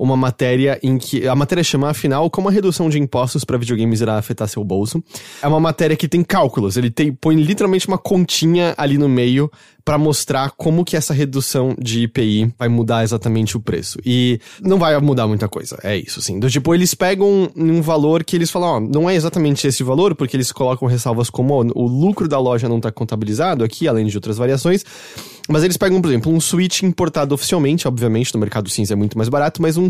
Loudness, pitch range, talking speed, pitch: -17 LUFS, 120-165 Hz, 220 wpm, 140 Hz